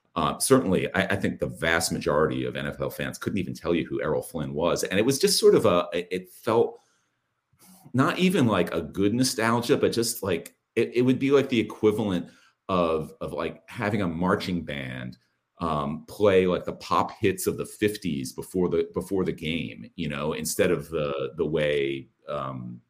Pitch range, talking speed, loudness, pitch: 80-120 Hz, 190 wpm, -26 LUFS, 95 Hz